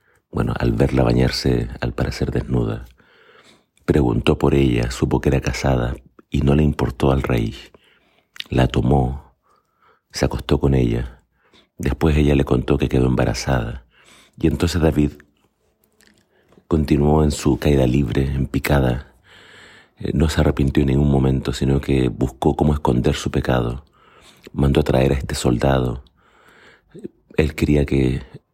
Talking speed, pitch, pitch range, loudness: 135 wpm, 70 Hz, 65-75 Hz, -19 LUFS